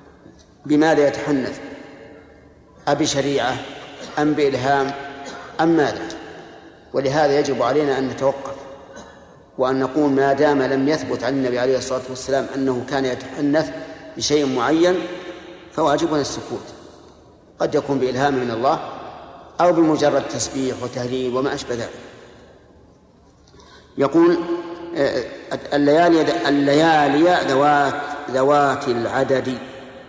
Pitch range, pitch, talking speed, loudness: 135-150 Hz, 140 Hz, 95 wpm, -19 LUFS